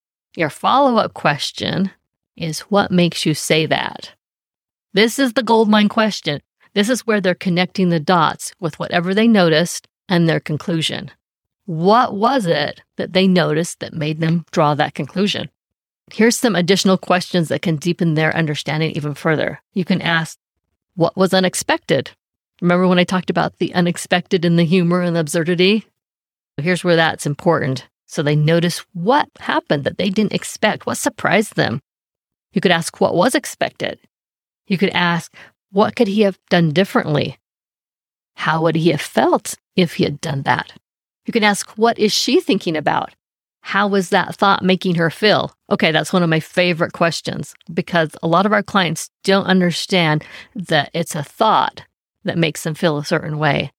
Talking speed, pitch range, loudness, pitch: 170 wpm, 165-195 Hz, -17 LUFS, 175 Hz